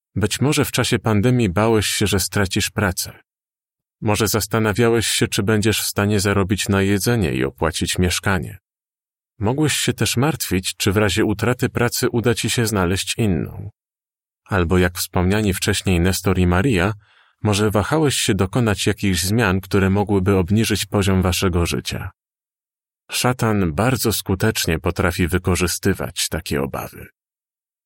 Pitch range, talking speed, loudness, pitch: 90-115 Hz, 135 wpm, -19 LUFS, 100 Hz